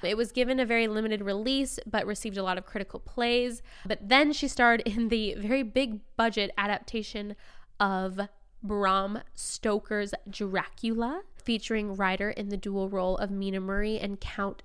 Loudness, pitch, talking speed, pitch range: -29 LUFS, 215 Hz, 160 wpm, 200-235 Hz